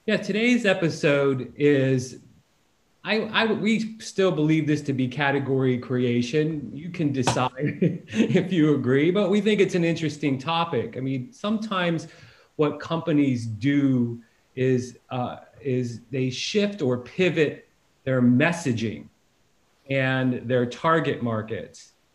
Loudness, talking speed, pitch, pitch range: -24 LUFS, 125 wpm, 145 Hz, 125-170 Hz